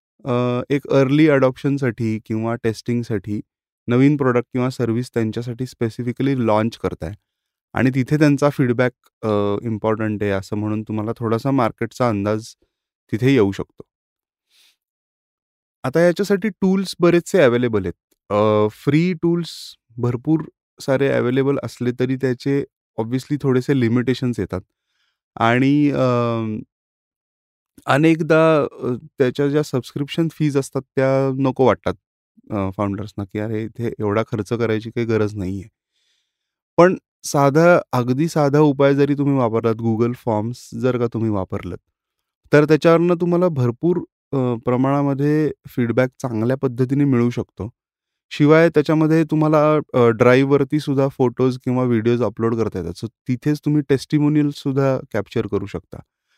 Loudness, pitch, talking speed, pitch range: -19 LUFS, 125 Hz, 115 wpm, 115-145 Hz